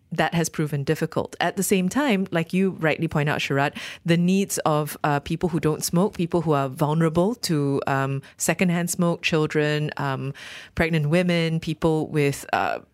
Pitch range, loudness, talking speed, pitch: 150-175 Hz, -23 LUFS, 170 wpm, 160 Hz